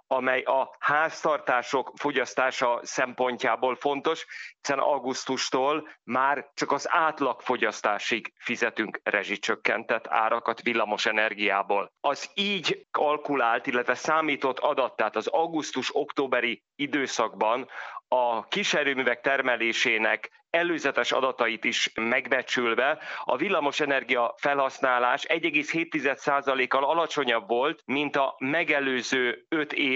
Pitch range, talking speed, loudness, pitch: 120-145 Hz, 90 wpm, -26 LUFS, 130 Hz